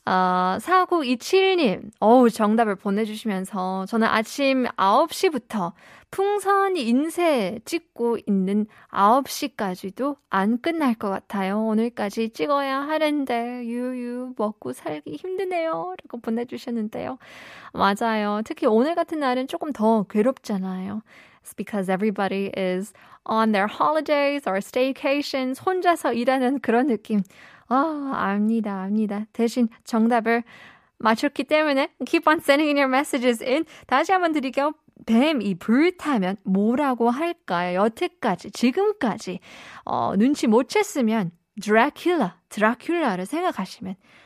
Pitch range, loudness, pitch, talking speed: 210-290 Hz, -23 LUFS, 240 Hz, 345 characters per minute